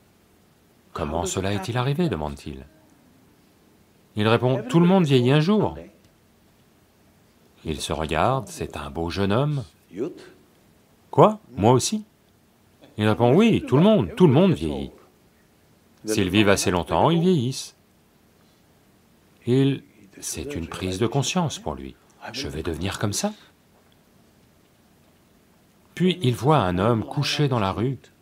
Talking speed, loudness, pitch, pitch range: 130 wpm, -22 LUFS, 110 Hz, 90-145 Hz